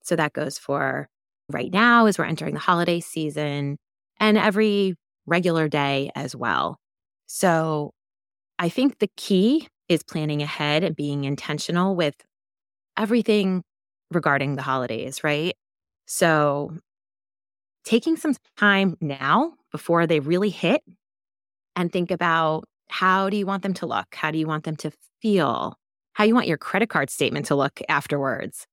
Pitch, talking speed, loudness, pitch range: 170 Hz, 150 wpm, -23 LUFS, 150-195 Hz